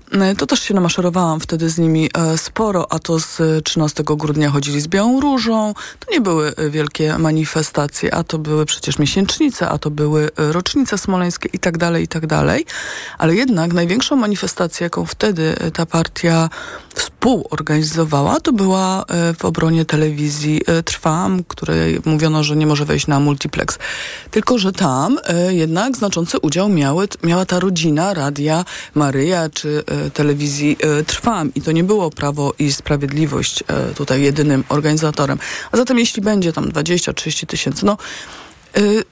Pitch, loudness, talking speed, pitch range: 165 Hz, -16 LUFS, 145 wpm, 150-185 Hz